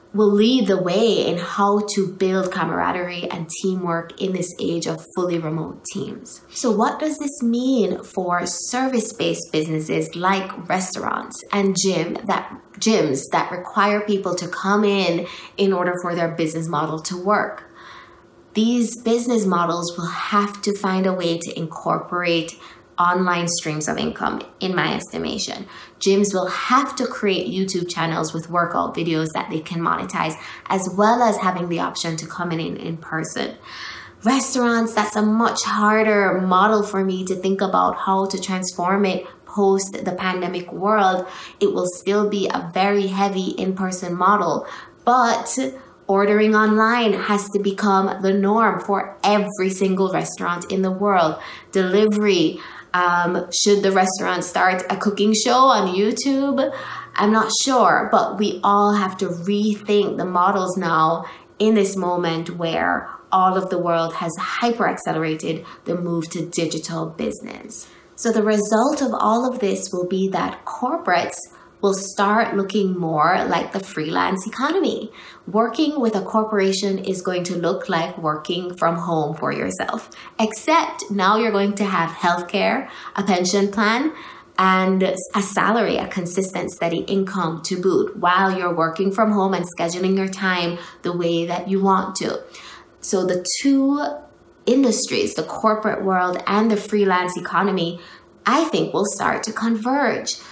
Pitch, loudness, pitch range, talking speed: 195 Hz, -20 LUFS, 180-215 Hz, 155 wpm